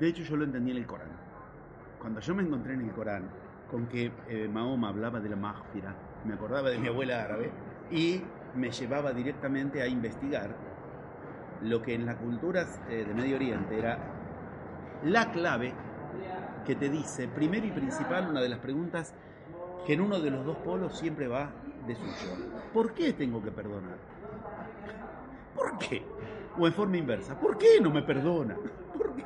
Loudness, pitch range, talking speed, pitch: -32 LUFS, 115-170 Hz, 170 wpm, 130 Hz